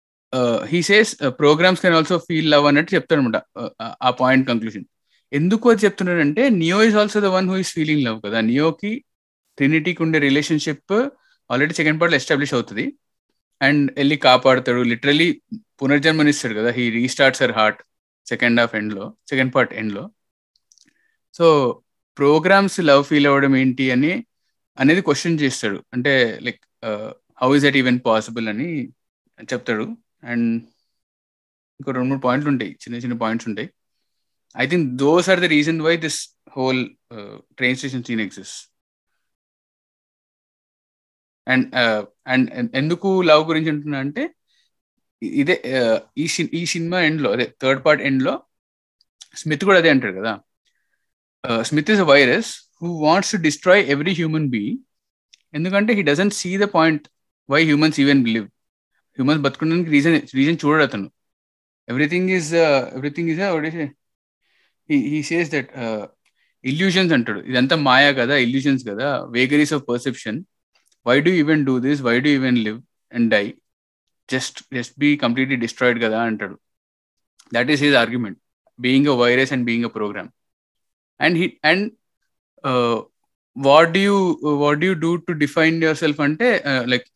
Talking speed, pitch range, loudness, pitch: 140 wpm, 125-170 Hz, -18 LUFS, 145 Hz